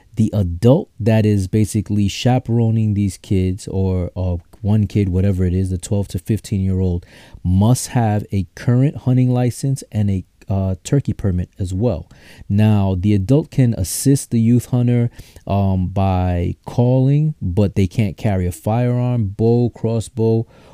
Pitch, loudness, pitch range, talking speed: 105 Hz, -18 LUFS, 95-120 Hz, 155 wpm